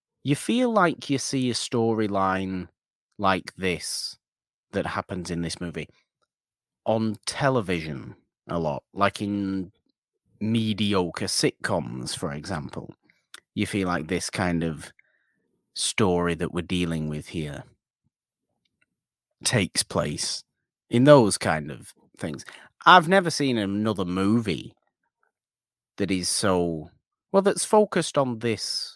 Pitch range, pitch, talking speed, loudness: 90-120 Hz, 100 Hz, 115 wpm, -25 LUFS